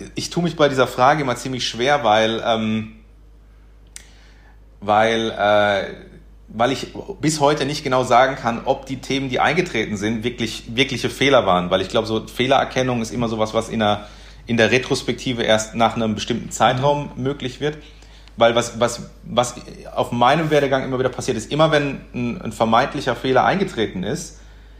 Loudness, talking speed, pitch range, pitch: -19 LUFS, 175 wpm, 110-135 Hz, 120 Hz